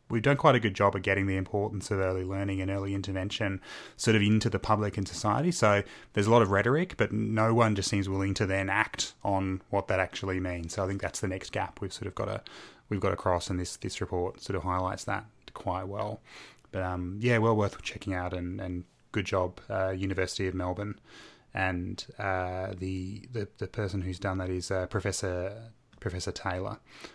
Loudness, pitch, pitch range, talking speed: -30 LUFS, 100 Hz, 95-110 Hz, 215 wpm